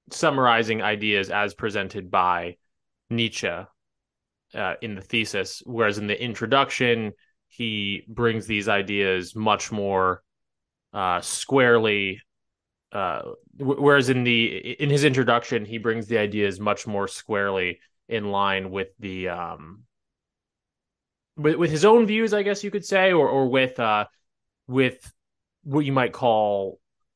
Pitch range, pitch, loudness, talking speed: 100-130 Hz, 110 Hz, -23 LUFS, 135 wpm